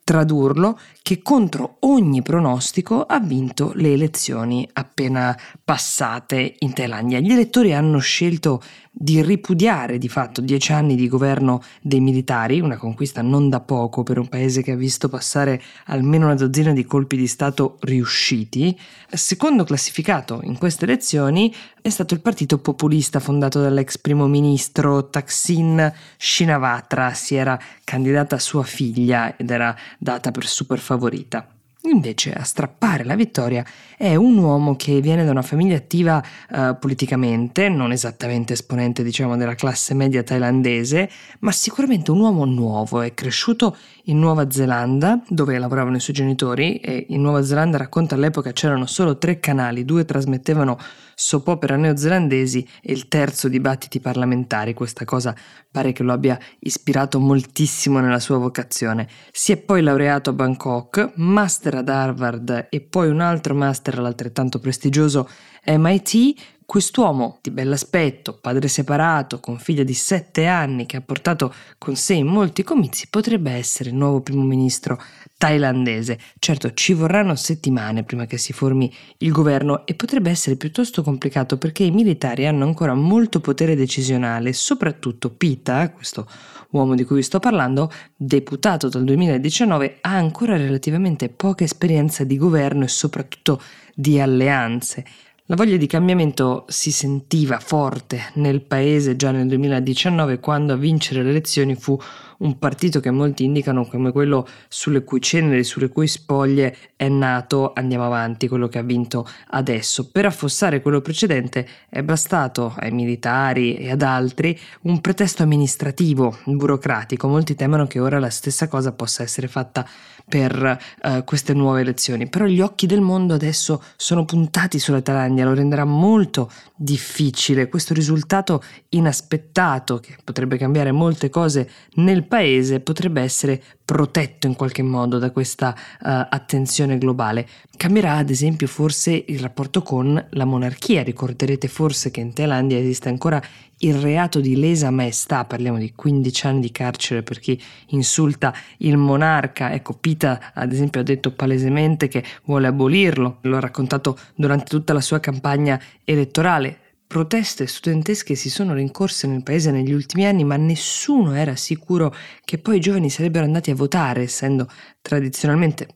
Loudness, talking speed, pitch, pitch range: -19 LUFS, 150 wpm, 140 Hz, 130-160 Hz